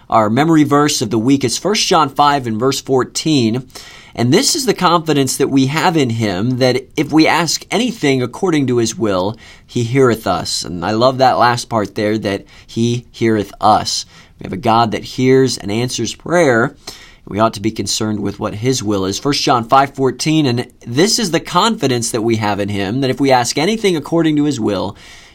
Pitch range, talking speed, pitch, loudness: 110-145 Hz, 210 wpm, 125 Hz, -15 LUFS